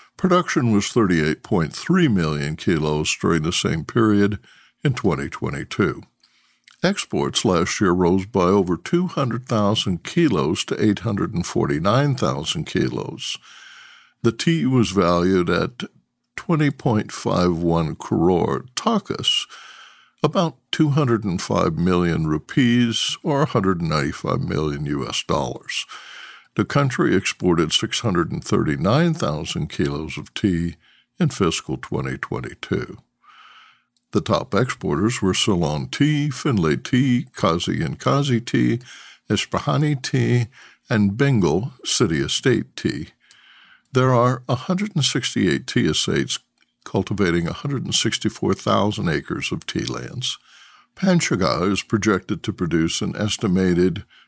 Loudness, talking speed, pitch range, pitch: -21 LUFS, 110 wpm, 90-140 Hz, 110 Hz